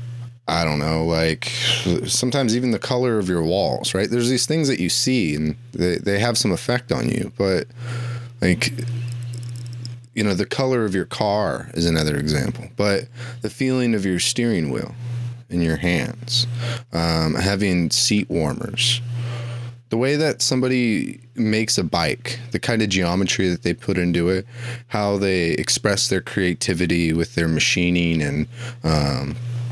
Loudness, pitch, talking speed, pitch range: -21 LUFS, 115 Hz, 160 wpm, 90-120 Hz